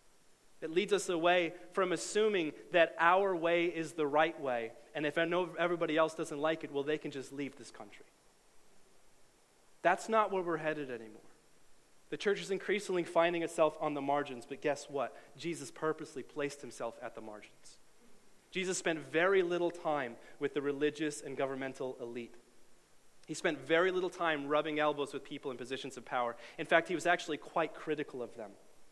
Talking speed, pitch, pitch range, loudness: 180 wpm, 155 Hz, 140-170 Hz, -34 LUFS